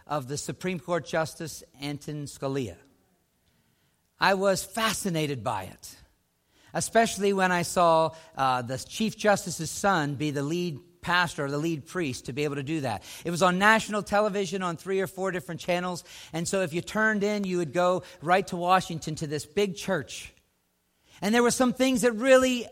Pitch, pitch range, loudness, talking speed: 175 Hz, 150-195 Hz, -27 LUFS, 180 wpm